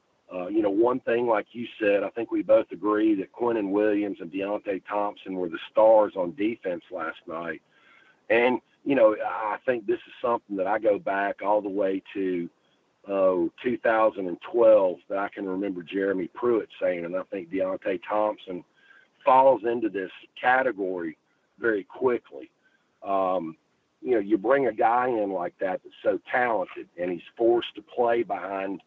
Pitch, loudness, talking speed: 105 Hz, -26 LUFS, 170 wpm